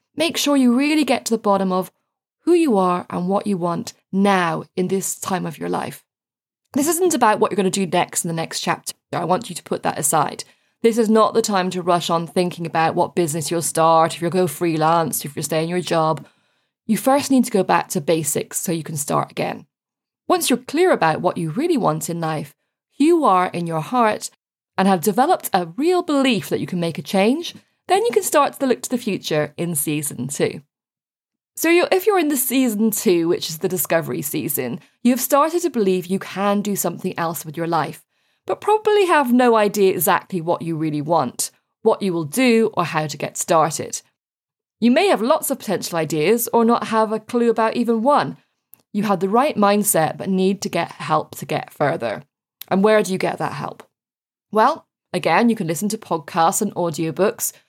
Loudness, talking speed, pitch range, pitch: -19 LUFS, 215 wpm, 170-240 Hz, 195 Hz